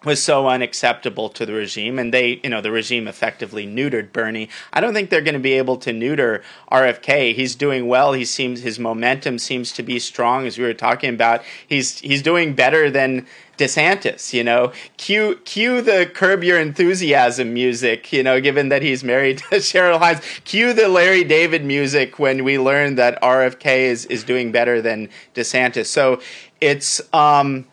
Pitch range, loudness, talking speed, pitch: 120-150 Hz, -17 LUFS, 180 wpm, 130 Hz